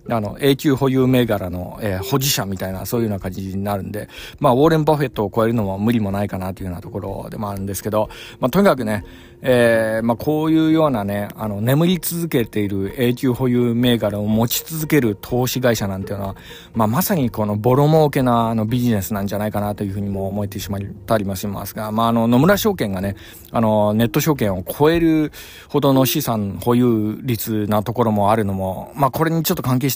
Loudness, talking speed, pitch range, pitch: -19 LUFS, 440 characters per minute, 100-130 Hz, 110 Hz